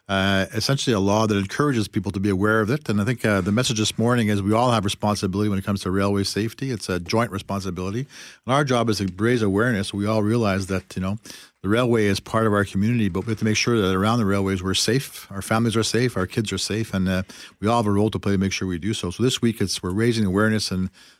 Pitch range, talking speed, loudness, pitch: 95-115 Hz, 275 wpm, -22 LUFS, 105 Hz